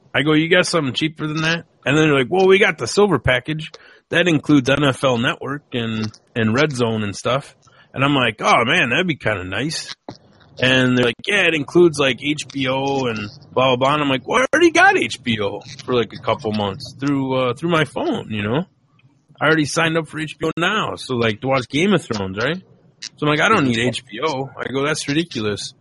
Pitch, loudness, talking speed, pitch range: 140 Hz, -18 LUFS, 225 wpm, 125-160 Hz